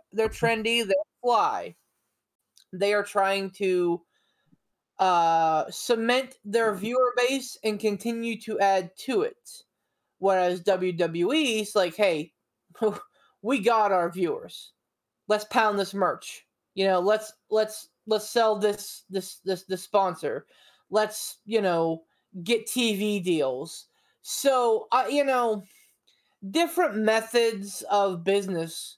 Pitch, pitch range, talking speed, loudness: 215 Hz, 190-235 Hz, 120 wpm, -26 LUFS